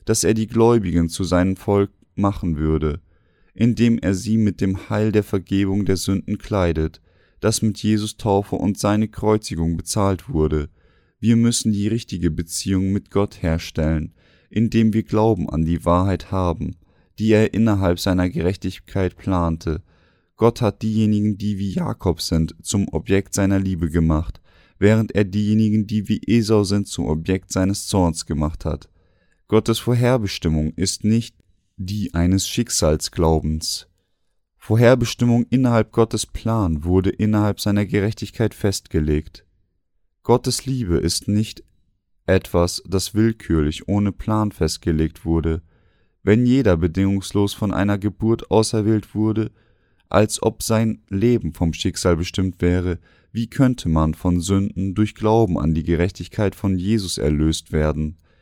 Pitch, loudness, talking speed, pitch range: 95 Hz, -20 LUFS, 135 wpm, 85-110 Hz